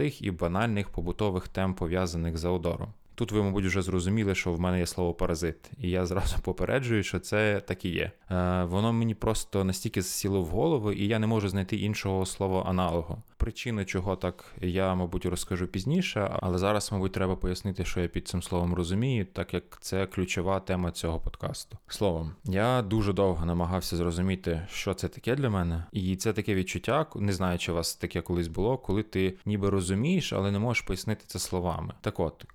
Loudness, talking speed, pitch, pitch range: -30 LUFS, 190 wpm, 95 Hz, 90-105 Hz